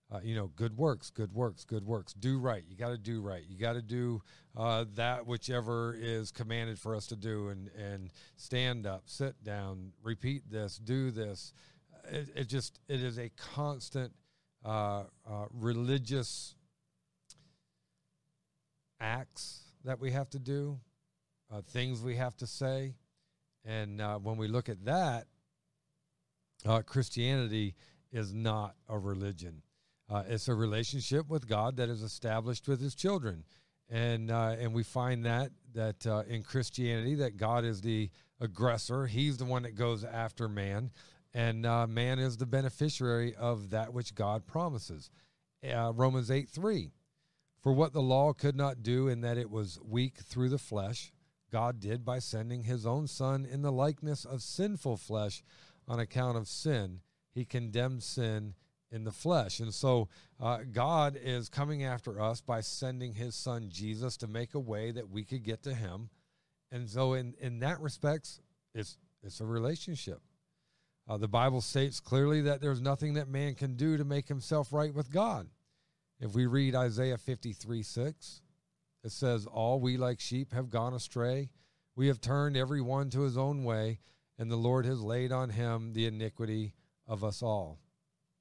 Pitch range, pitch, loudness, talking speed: 110-140 Hz, 125 Hz, -35 LUFS, 170 wpm